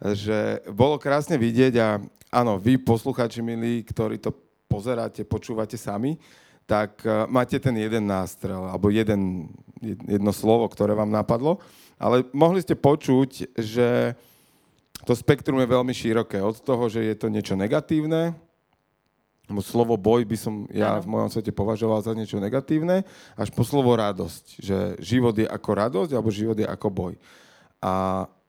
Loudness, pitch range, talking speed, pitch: -24 LUFS, 105-125 Hz, 150 wpm, 115 Hz